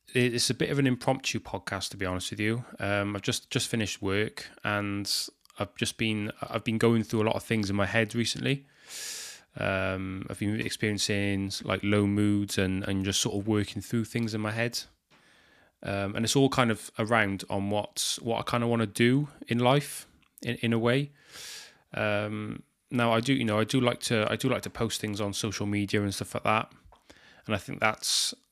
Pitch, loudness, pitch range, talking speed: 110 Hz, -29 LUFS, 100-120 Hz, 215 wpm